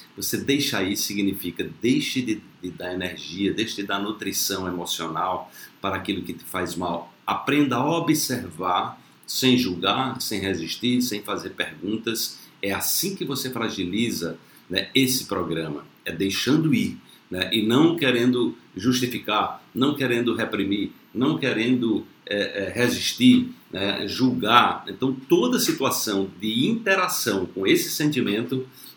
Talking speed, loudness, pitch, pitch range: 135 wpm, -24 LUFS, 110 Hz, 95-130 Hz